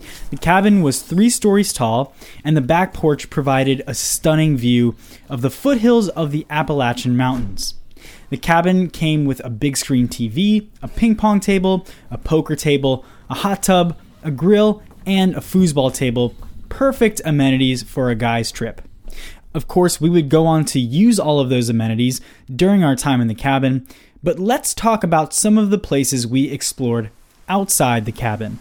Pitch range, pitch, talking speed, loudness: 125-185 Hz, 145 Hz, 170 wpm, -17 LUFS